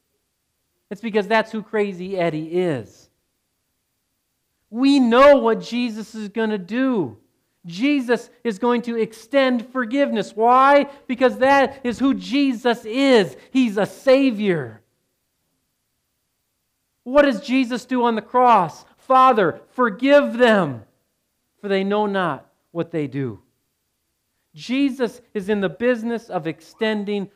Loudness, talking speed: -19 LUFS, 120 wpm